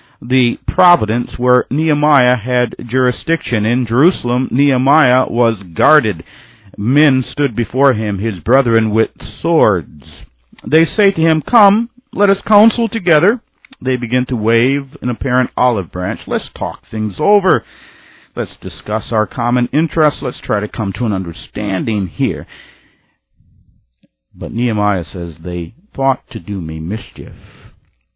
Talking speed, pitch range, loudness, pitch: 130 wpm, 105-145 Hz, -14 LUFS, 125 Hz